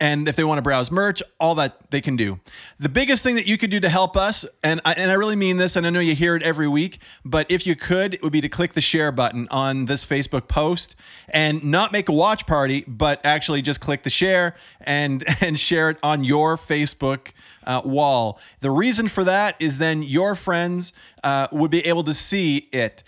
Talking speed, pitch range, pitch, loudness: 230 wpm, 145-180 Hz, 155 Hz, -20 LUFS